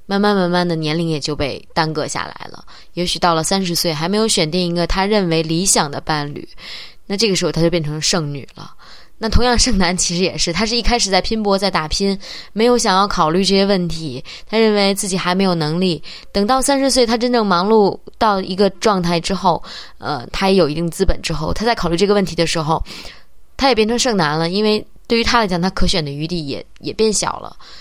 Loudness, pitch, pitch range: -17 LUFS, 185 Hz, 170-215 Hz